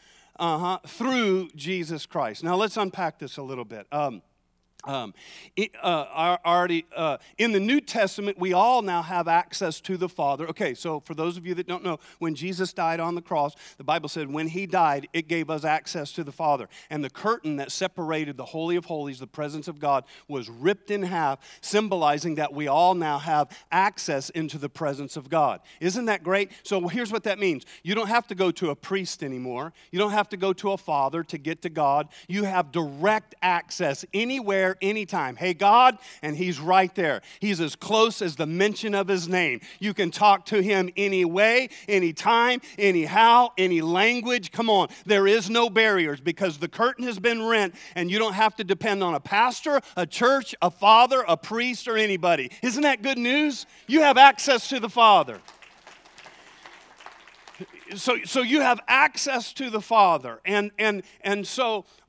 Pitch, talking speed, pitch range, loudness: 185 Hz, 190 wpm, 165-220 Hz, -24 LUFS